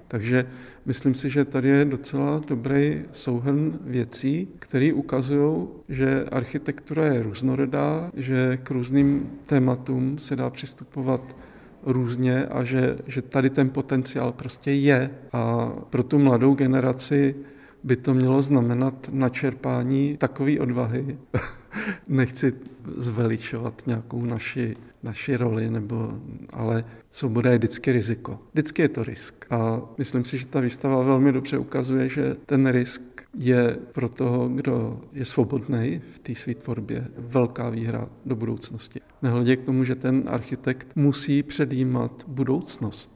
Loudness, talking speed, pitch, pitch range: -24 LUFS, 130 wpm, 130 Hz, 120-140 Hz